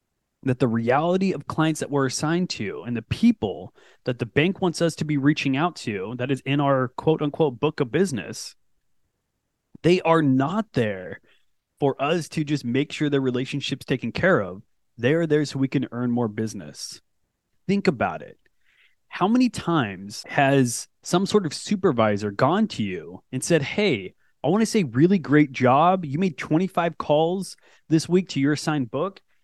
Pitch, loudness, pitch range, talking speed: 150 Hz, -23 LUFS, 130-175 Hz, 180 wpm